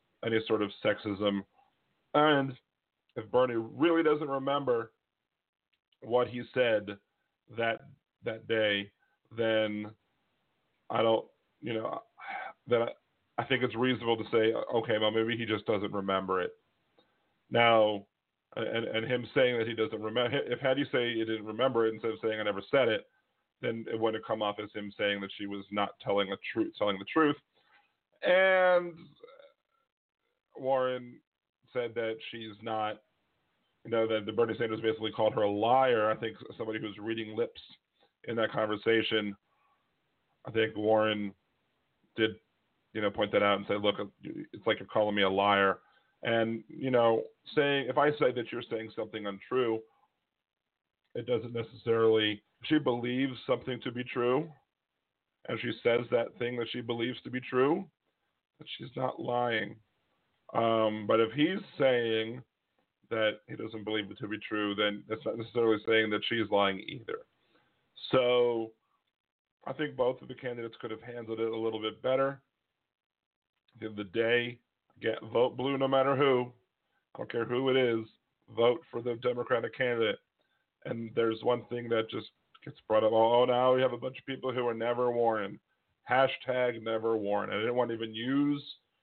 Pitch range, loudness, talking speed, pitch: 110-125 Hz, -31 LUFS, 165 wpm, 115 Hz